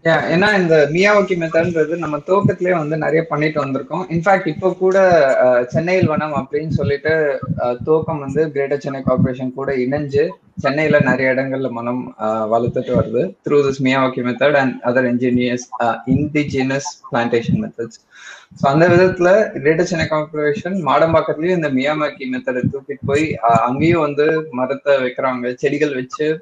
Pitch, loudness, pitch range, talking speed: 145 Hz, -17 LUFS, 130-160 Hz, 130 wpm